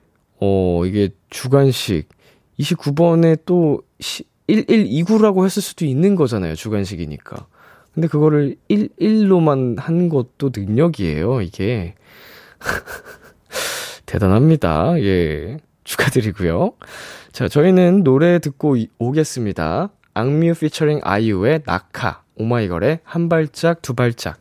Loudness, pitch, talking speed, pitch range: -17 LUFS, 140 Hz, 225 characters per minute, 105-165 Hz